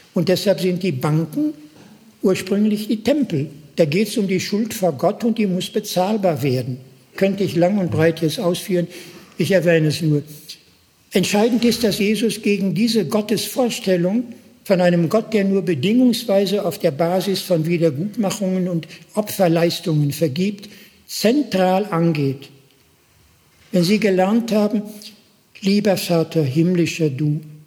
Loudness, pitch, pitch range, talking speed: -19 LUFS, 185 Hz, 170-210 Hz, 135 wpm